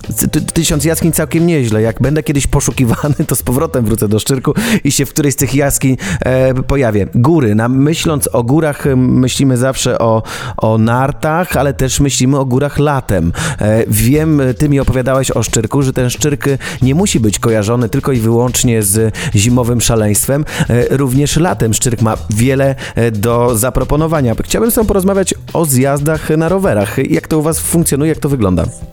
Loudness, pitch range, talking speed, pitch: -12 LUFS, 115-150 Hz, 165 wpm, 135 Hz